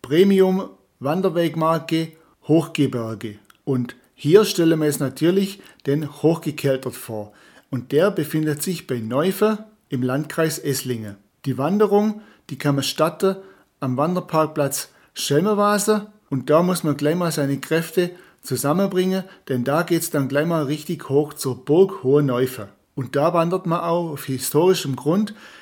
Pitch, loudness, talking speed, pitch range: 155 Hz, -21 LUFS, 140 wpm, 135-180 Hz